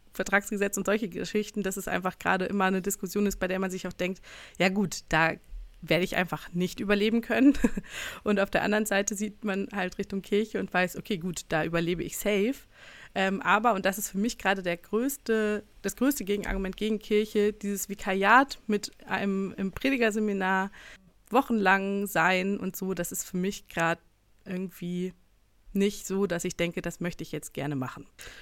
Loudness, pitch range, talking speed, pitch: -28 LUFS, 185-210 Hz, 180 wpm, 195 Hz